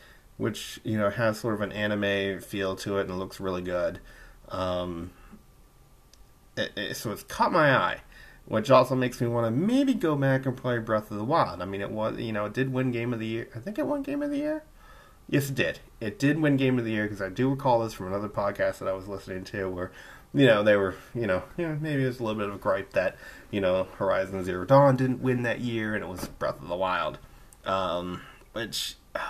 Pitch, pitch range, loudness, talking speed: 110 Hz, 95-130 Hz, -28 LUFS, 245 wpm